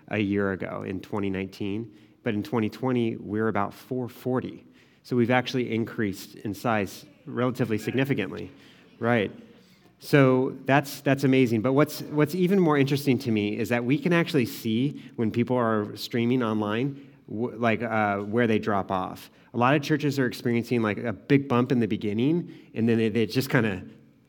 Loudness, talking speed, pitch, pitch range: -26 LUFS, 170 wpm, 120 Hz, 110-135 Hz